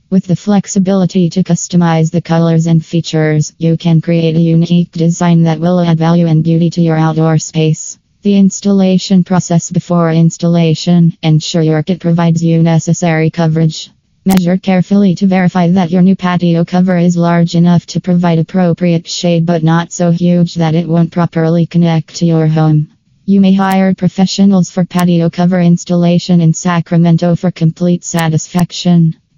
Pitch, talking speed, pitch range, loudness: 170 Hz, 160 wpm, 165-180 Hz, -11 LUFS